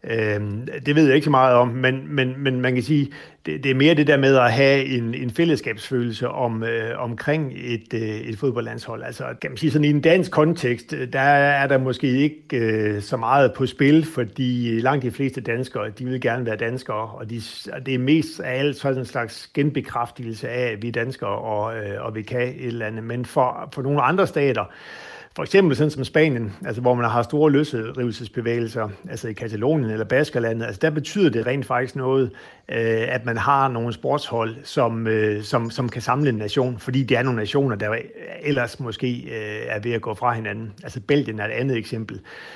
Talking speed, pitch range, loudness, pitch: 210 wpm, 115-140 Hz, -22 LUFS, 125 Hz